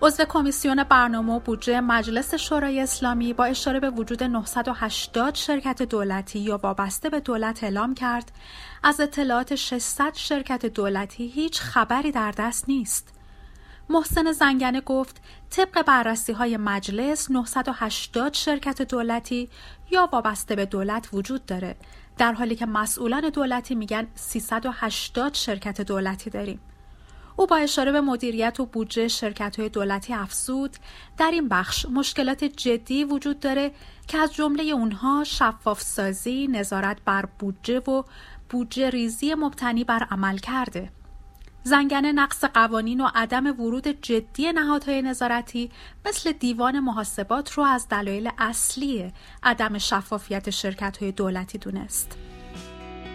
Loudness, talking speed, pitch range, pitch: -24 LUFS, 130 wpm, 215-275 Hz, 240 Hz